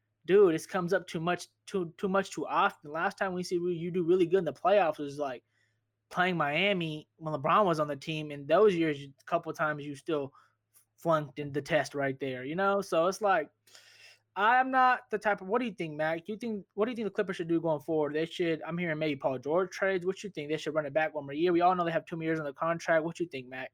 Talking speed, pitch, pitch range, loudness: 275 wpm, 165 Hz, 150-190 Hz, -30 LUFS